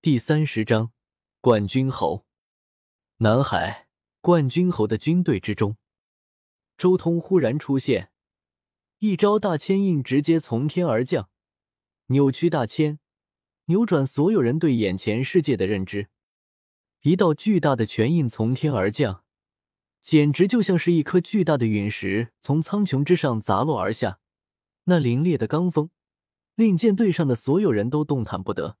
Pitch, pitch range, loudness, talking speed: 145 Hz, 110-170 Hz, -22 LUFS, 215 characters per minute